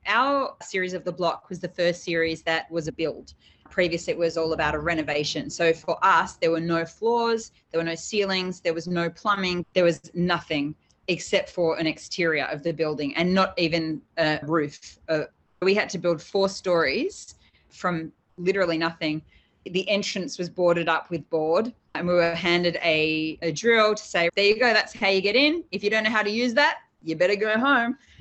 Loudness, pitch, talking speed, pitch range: -24 LUFS, 175 Hz, 205 wpm, 165-195 Hz